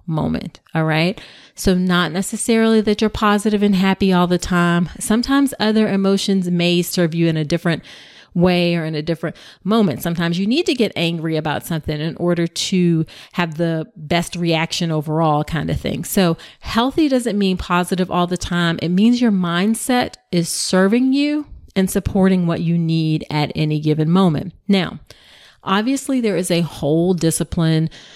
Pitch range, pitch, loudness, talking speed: 165-200 Hz, 175 Hz, -18 LUFS, 170 wpm